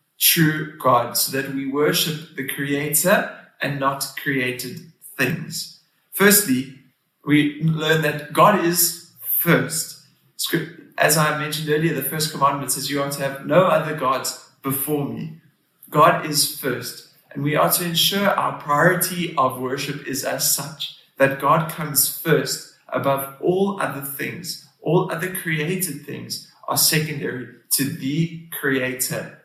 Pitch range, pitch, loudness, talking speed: 135-165 Hz, 150 Hz, -20 LUFS, 140 wpm